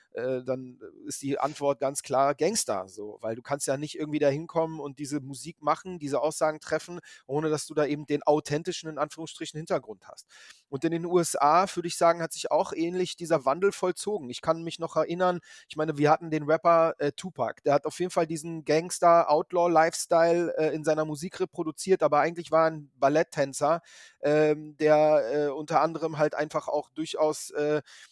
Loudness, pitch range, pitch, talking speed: -27 LUFS, 150-165 Hz, 155 Hz, 190 wpm